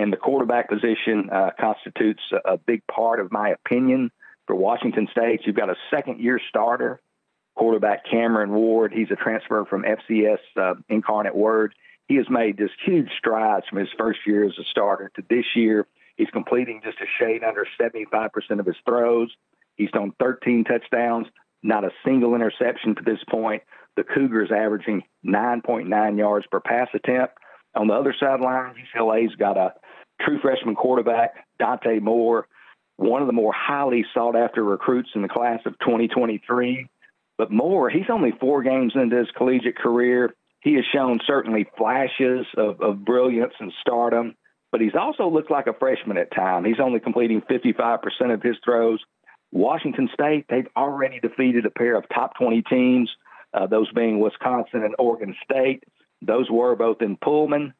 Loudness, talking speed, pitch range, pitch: -22 LUFS, 170 wpm, 110-125 Hz, 115 Hz